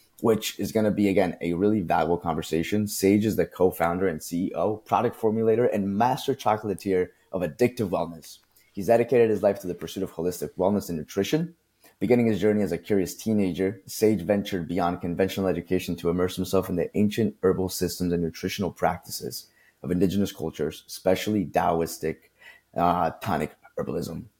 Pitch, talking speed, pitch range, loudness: 100 Hz, 165 wpm, 90-110 Hz, -26 LUFS